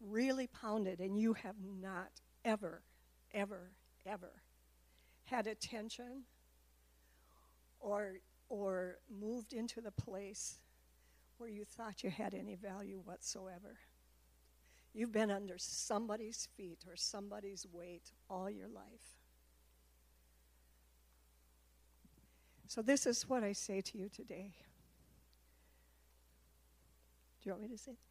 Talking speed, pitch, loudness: 110 wpm, 185 Hz, -43 LUFS